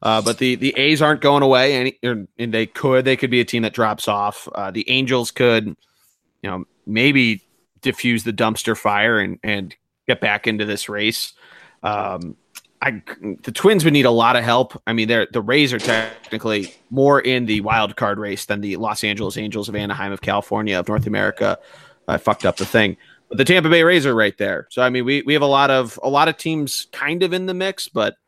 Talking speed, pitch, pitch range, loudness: 225 wpm, 120 Hz, 105-135 Hz, -18 LUFS